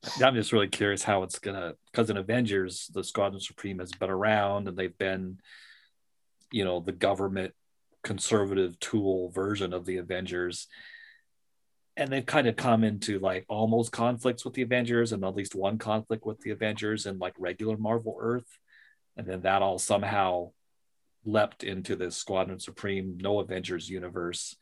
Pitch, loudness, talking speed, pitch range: 100 Hz, -30 LUFS, 165 wpm, 95-110 Hz